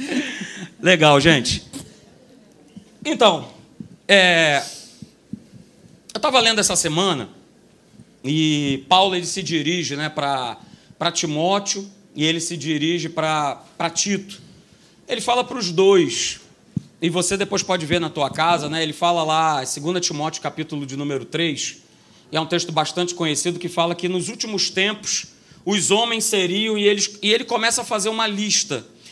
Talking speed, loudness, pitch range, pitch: 145 wpm, -19 LUFS, 155-200 Hz, 175 Hz